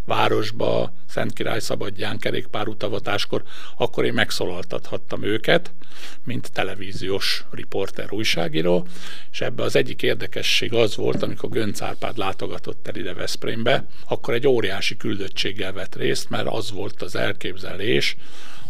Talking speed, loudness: 125 wpm, -24 LUFS